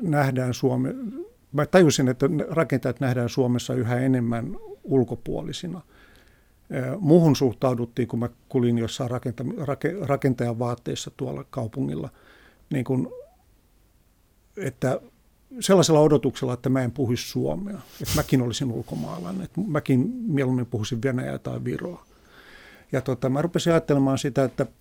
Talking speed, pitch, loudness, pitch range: 120 wpm, 135 Hz, -24 LUFS, 125-150 Hz